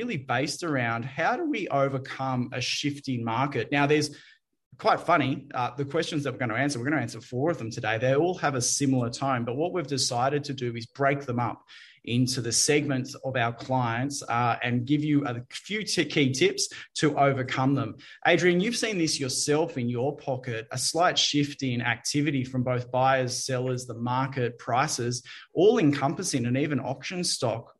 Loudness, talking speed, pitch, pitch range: -27 LUFS, 195 wpm, 135 Hz, 125-150 Hz